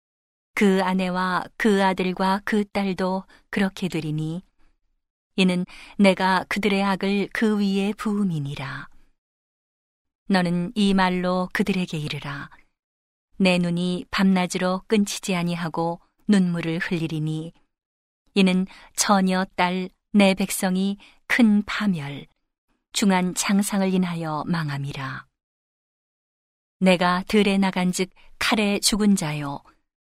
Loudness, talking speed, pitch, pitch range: -23 LUFS, 210 characters per minute, 185 Hz, 175-200 Hz